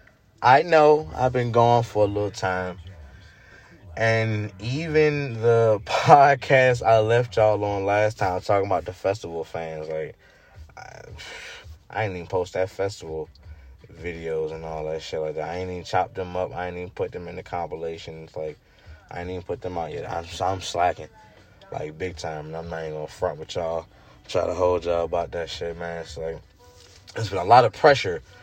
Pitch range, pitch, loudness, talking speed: 80-105 Hz, 90 Hz, -23 LUFS, 195 wpm